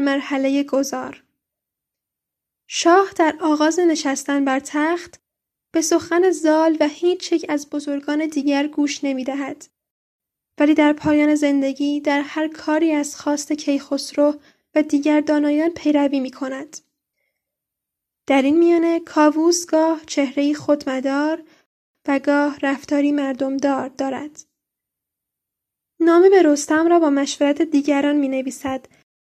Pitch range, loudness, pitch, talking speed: 280-315 Hz, -19 LUFS, 295 Hz, 115 wpm